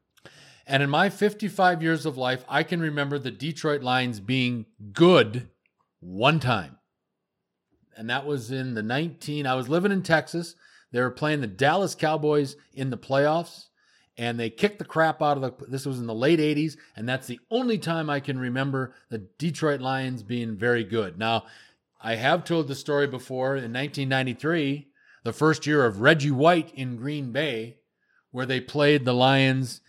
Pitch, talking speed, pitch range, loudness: 140 Hz, 175 wpm, 125-155 Hz, -25 LUFS